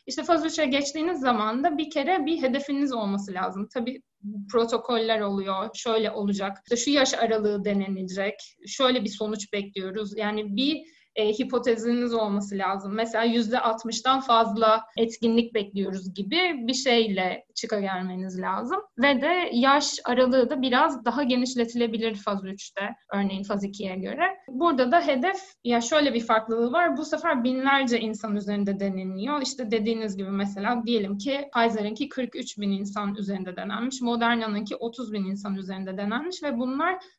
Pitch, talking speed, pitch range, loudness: 230 Hz, 145 wpm, 205-265 Hz, -26 LUFS